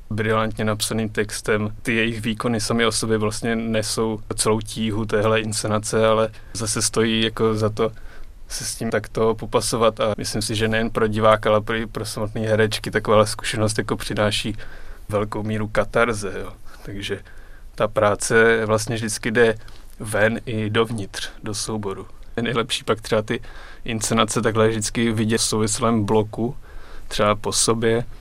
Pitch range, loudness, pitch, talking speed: 105-115 Hz, -21 LUFS, 110 Hz, 155 wpm